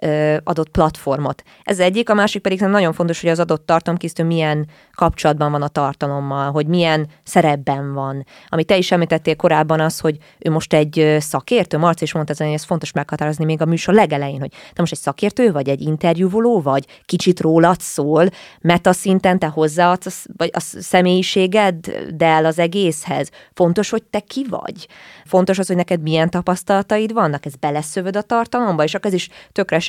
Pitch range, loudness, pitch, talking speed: 155-185 Hz, -17 LUFS, 165 Hz, 175 wpm